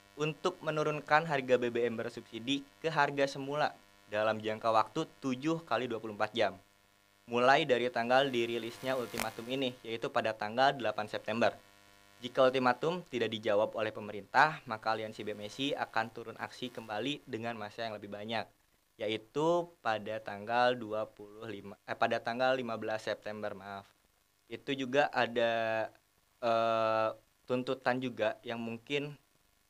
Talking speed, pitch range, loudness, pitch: 125 wpm, 105-130 Hz, -34 LUFS, 115 Hz